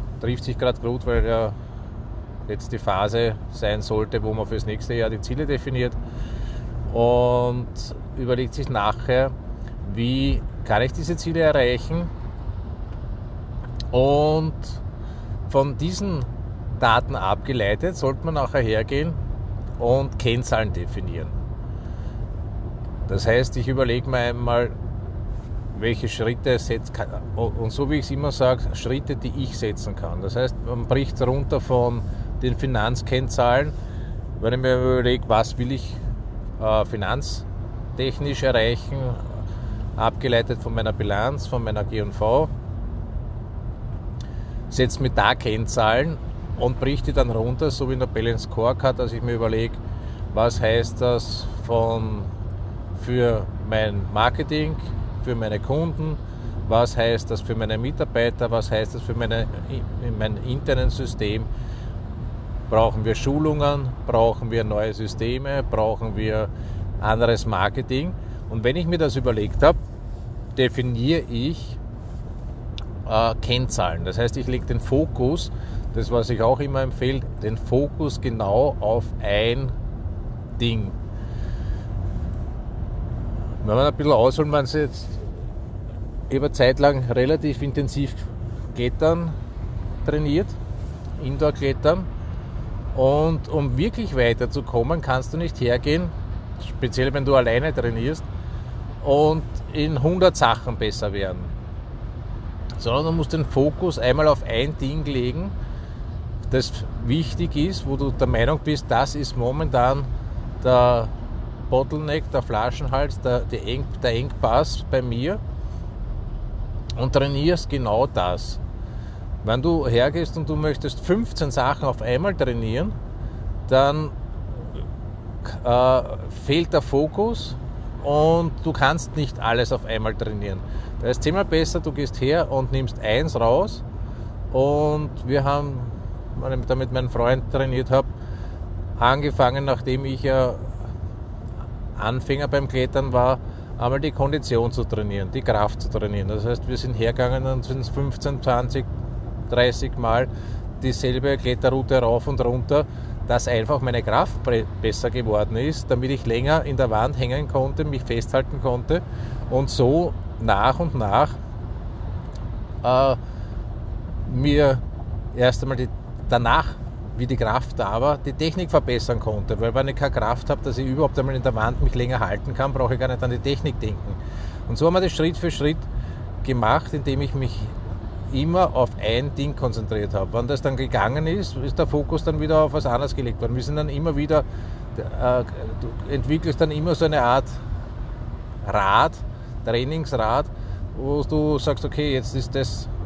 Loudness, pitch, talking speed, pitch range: -23 LUFS, 120 Hz, 135 wpm, 105-130 Hz